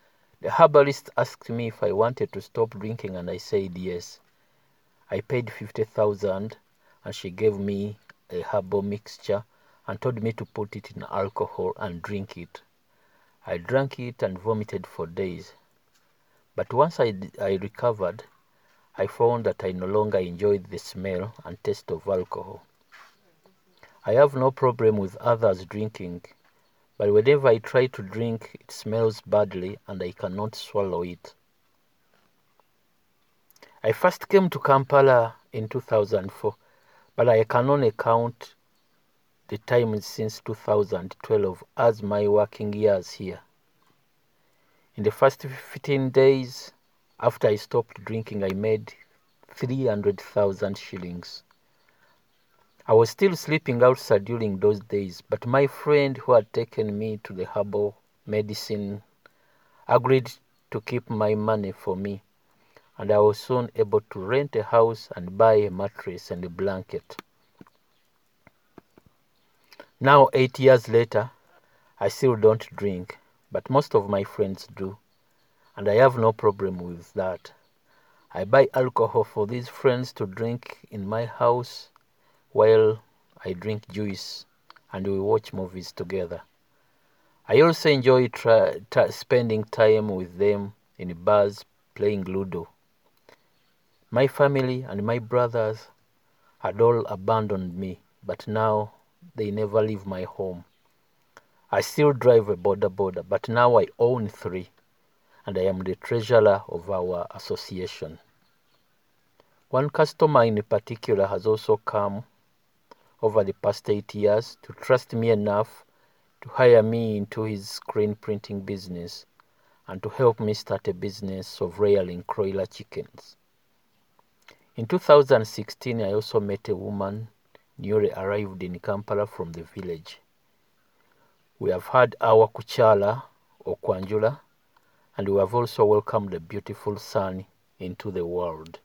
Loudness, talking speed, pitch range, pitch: -24 LUFS, 135 wpm, 100-125 Hz, 110 Hz